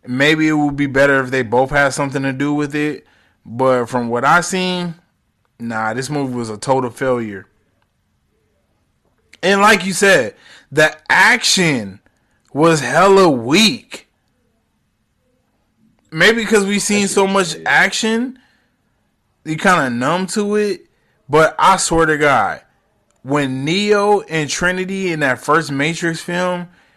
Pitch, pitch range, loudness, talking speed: 155 Hz, 135-190 Hz, -15 LUFS, 140 wpm